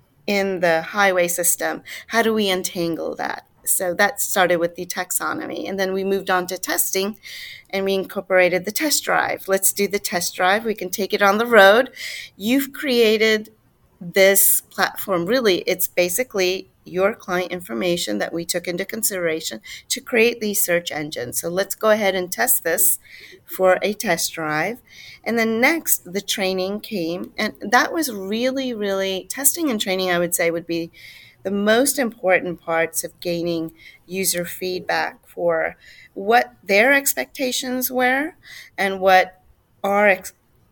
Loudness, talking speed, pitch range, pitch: -20 LUFS, 160 wpm, 175-215 Hz, 190 Hz